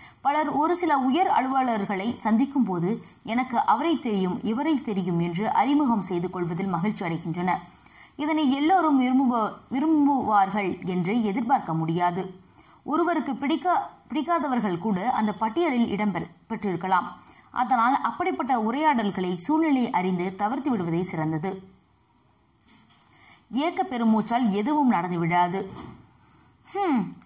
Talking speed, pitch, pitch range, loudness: 80 wpm, 225 Hz, 185-285 Hz, -25 LUFS